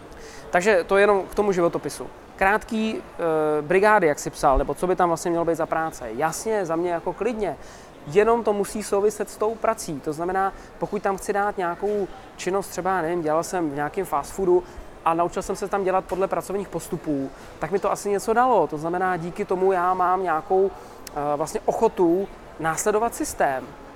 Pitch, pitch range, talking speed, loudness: 185 Hz, 165-200 Hz, 195 wpm, -23 LUFS